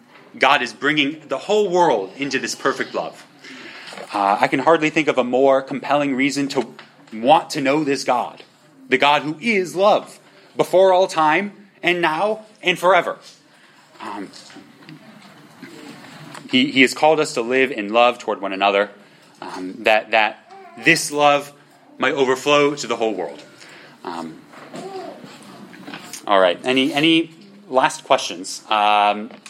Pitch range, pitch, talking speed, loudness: 130-175 Hz, 145 Hz, 140 wpm, -18 LUFS